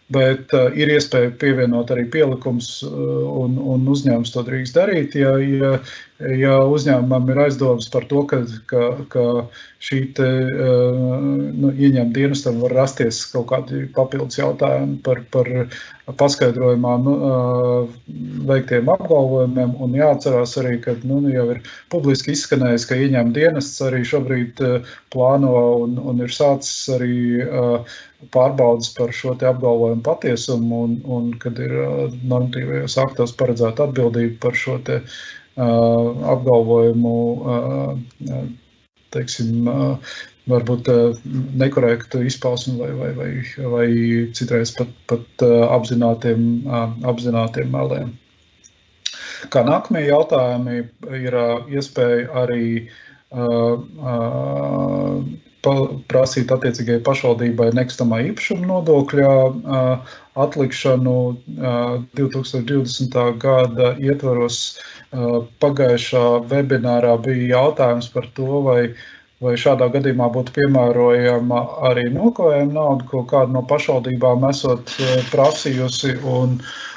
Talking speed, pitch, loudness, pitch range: 100 wpm, 125 Hz, -18 LUFS, 120-135 Hz